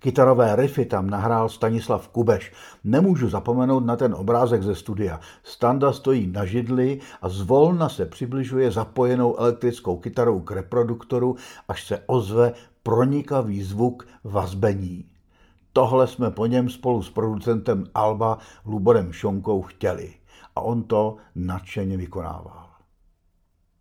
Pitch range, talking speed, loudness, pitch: 95-125 Hz, 120 wpm, -23 LUFS, 115 Hz